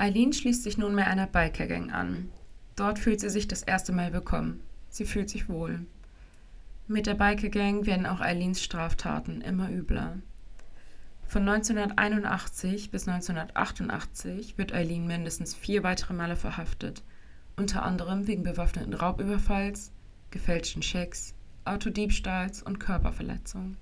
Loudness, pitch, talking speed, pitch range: -30 LUFS, 185 Hz, 125 wpm, 165-205 Hz